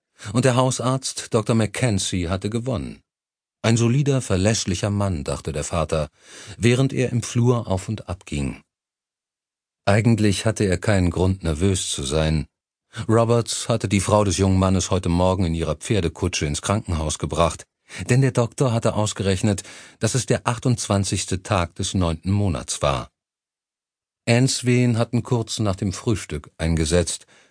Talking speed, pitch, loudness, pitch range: 145 wpm, 100 Hz, -22 LUFS, 90-115 Hz